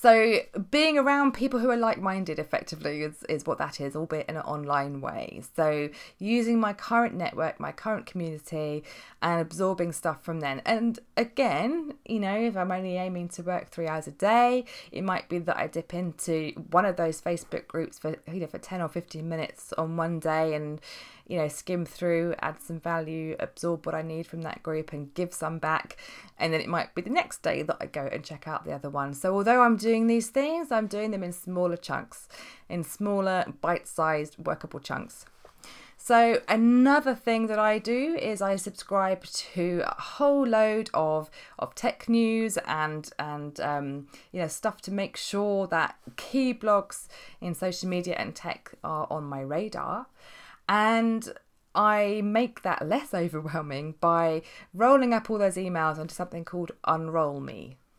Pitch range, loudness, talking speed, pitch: 160-220 Hz, -28 LUFS, 180 wpm, 180 Hz